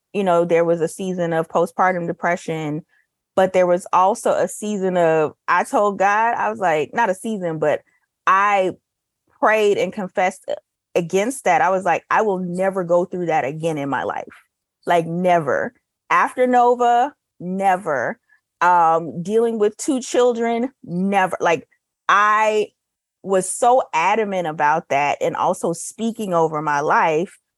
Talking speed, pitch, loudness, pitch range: 150 wpm, 185 Hz, -19 LUFS, 170-215 Hz